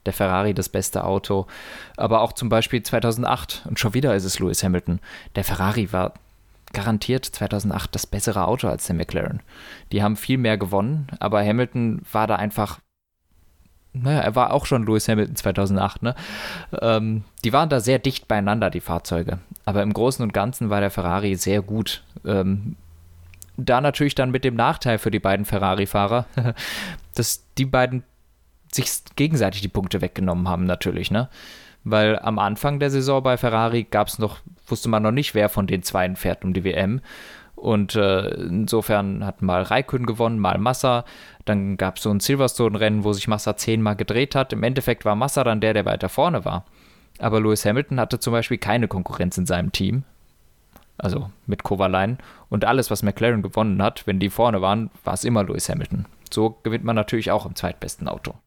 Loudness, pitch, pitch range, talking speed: -22 LUFS, 105 Hz, 95-120 Hz, 180 wpm